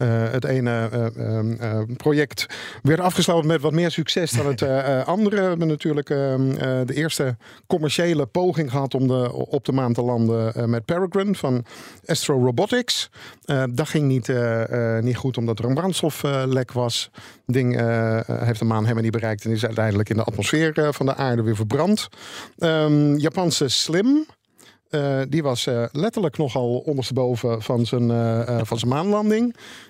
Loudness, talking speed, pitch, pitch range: -22 LUFS, 185 wpm, 135 Hz, 120-155 Hz